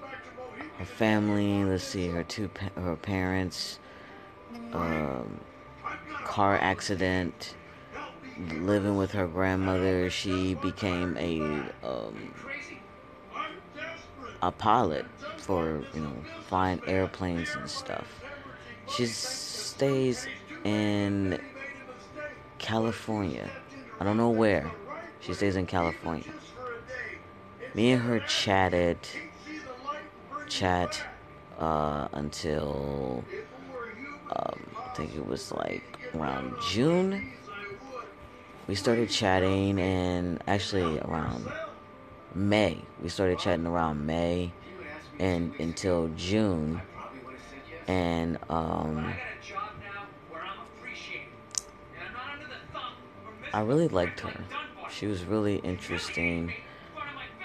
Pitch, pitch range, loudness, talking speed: 95 Hz, 85-105 Hz, -31 LUFS, 85 wpm